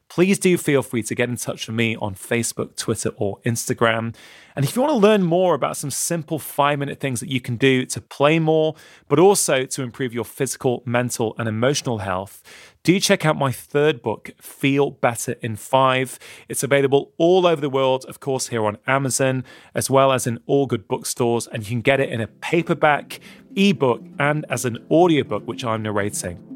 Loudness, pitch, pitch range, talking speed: -20 LUFS, 130 Hz, 120-150 Hz, 200 wpm